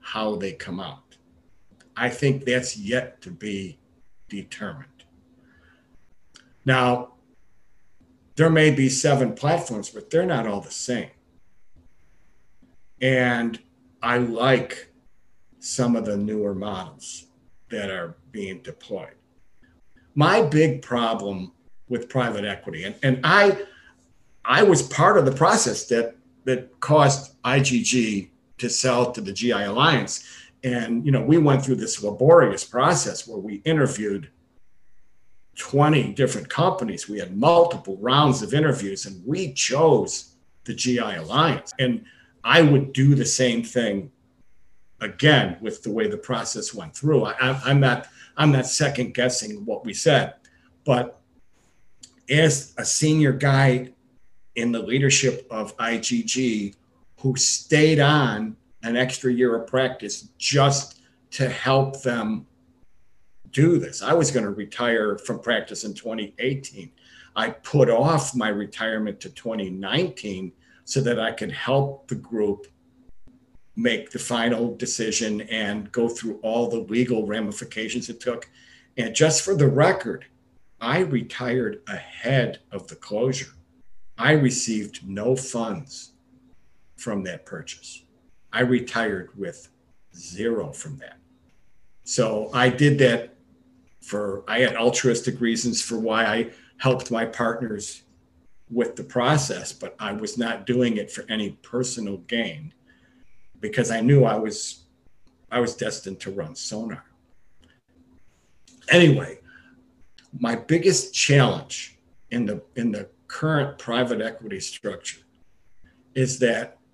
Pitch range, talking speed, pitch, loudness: 110-135 Hz, 125 wpm, 120 Hz, -22 LUFS